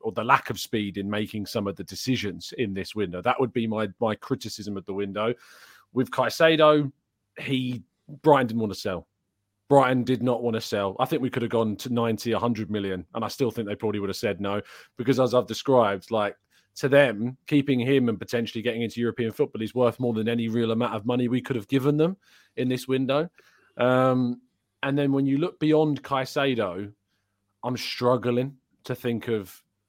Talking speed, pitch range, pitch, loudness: 205 wpm, 105-130 Hz, 120 Hz, -25 LUFS